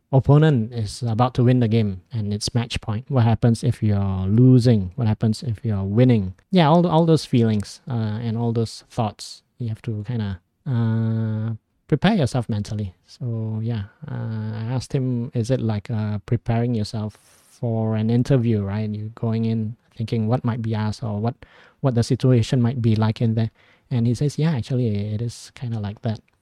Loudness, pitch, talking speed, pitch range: -22 LUFS, 115 Hz, 200 wpm, 110-125 Hz